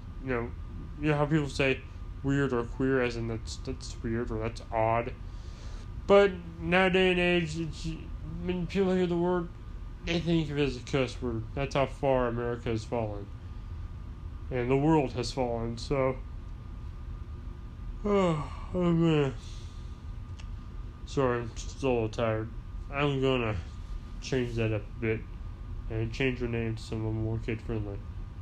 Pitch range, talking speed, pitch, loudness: 95-135 Hz, 150 wpm, 115 Hz, -30 LUFS